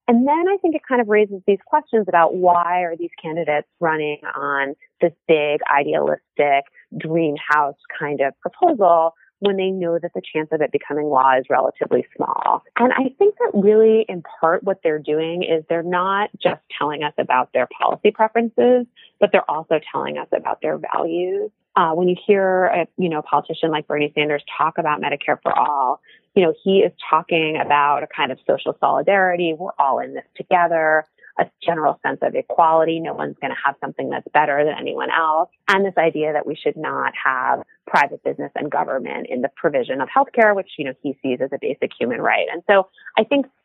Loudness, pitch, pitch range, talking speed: -19 LUFS, 175 Hz, 155-215 Hz, 200 wpm